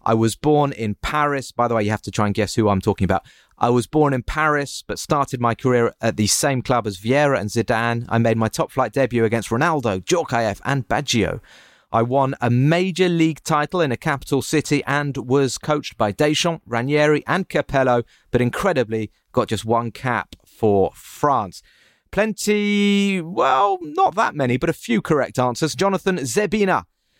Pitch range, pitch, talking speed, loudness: 115-155 Hz, 135 Hz, 185 wpm, -20 LUFS